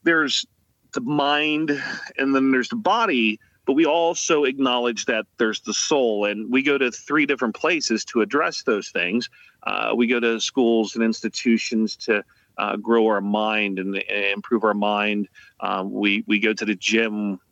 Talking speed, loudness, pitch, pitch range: 175 wpm, -21 LUFS, 110 Hz, 105-125 Hz